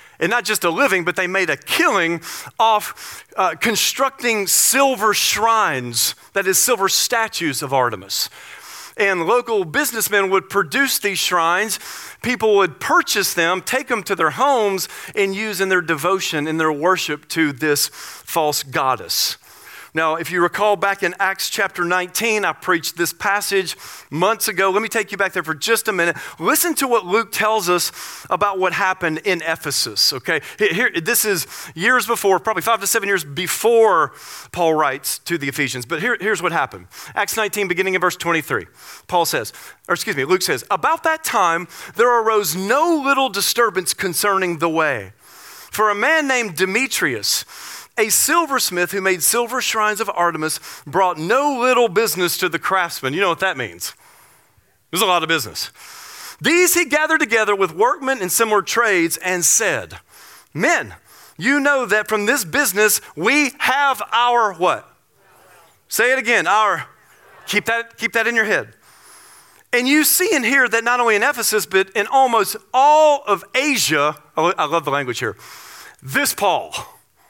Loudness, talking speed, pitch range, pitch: -17 LUFS, 170 wpm, 170-235 Hz, 200 Hz